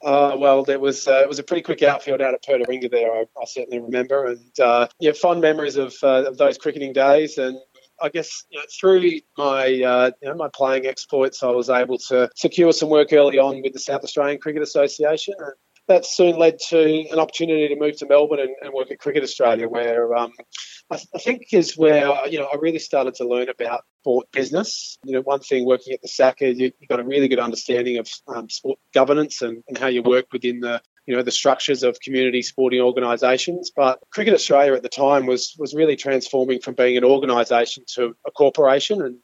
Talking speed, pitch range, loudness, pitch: 220 wpm, 125-150 Hz, -19 LUFS, 135 Hz